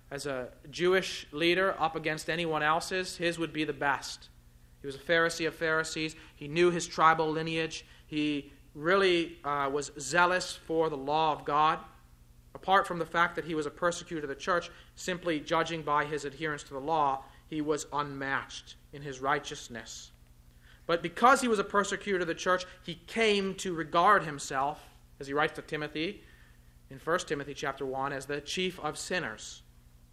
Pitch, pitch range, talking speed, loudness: 155 Hz, 140-170 Hz, 175 wpm, -30 LUFS